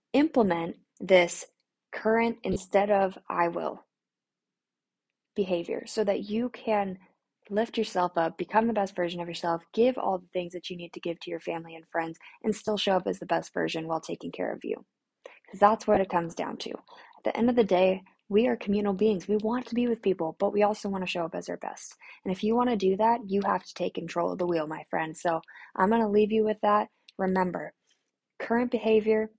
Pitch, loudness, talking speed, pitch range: 200 Hz, -28 LUFS, 225 wpm, 175-220 Hz